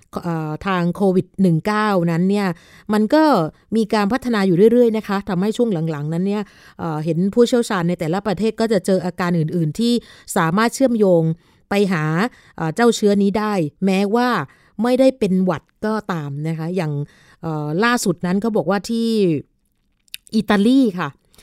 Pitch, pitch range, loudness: 195 Hz, 170-220 Hz, -19 LUFS